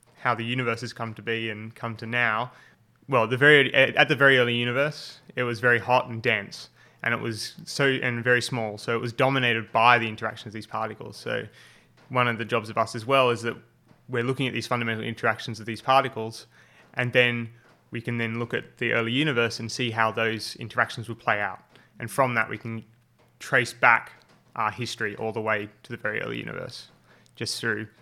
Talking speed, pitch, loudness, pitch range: 210 wpm, 115 Hz, -25 LUFS, 115-125 Hz